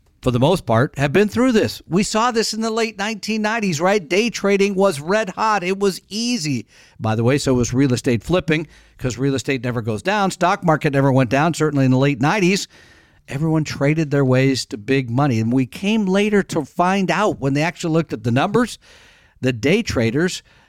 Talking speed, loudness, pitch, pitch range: 210 wpm, -19 LUFS, 155 Hz, 130-200 Hz